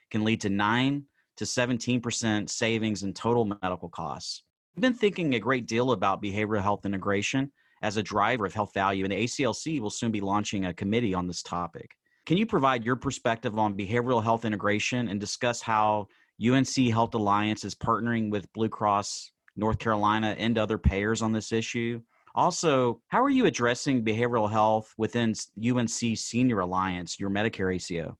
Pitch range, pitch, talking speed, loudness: 105-120 Hz, 110 Hz, 170 wpm, -27 LUFS